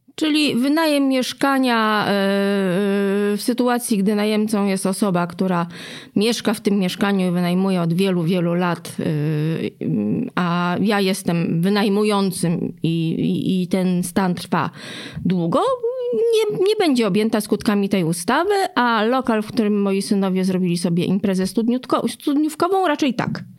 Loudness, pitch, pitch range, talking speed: -19 LUFS, 205 Hz, 185-240 Hz, 125 wpm